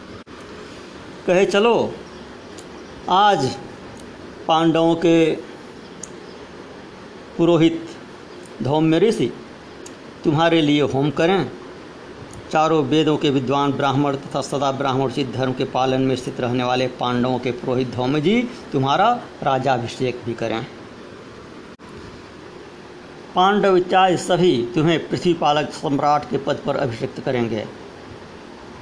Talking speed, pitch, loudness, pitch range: 100 wpm, 145 Hz, -19 LUFS, 130-165 Hz